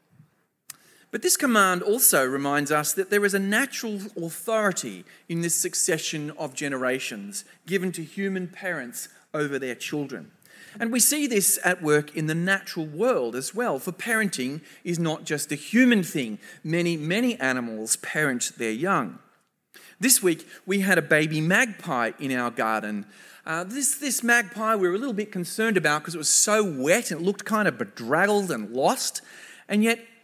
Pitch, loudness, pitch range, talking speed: 180 Hz, -24 LUFS, 155-215 Hz, 170 wpm